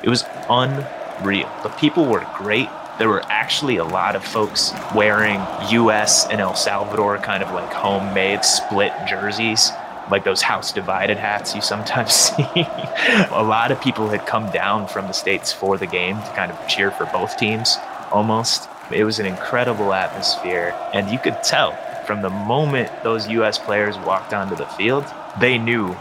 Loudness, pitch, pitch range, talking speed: -19 LUFS, 105 Hz, 105-115 Hz, 175 wpm